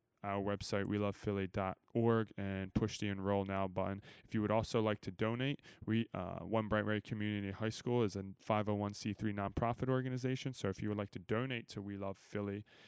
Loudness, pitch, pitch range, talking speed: -39 LUFS, 105 Hz, 100-115 Hz, 190 wpm